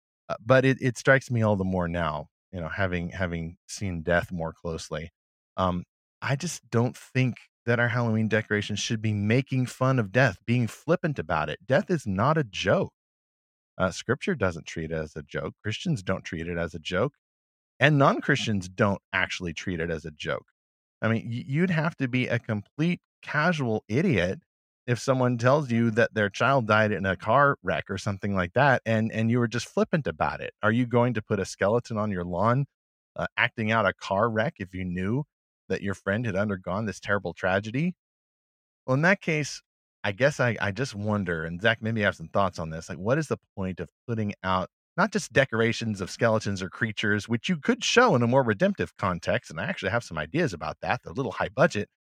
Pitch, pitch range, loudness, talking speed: 110 Hz, 95-125 Hz, -27 LUFS, 210 wpm